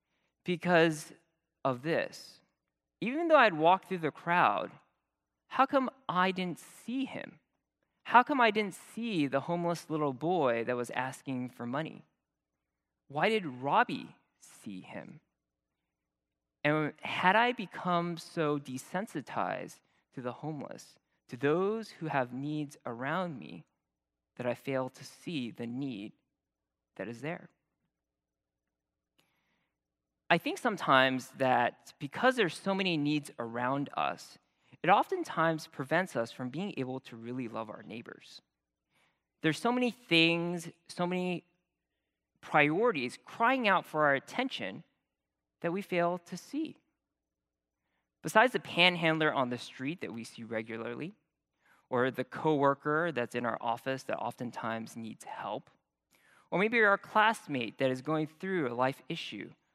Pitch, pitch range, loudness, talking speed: 150 Hz, 120-180 Hz, -31 LUFS, 135 wpm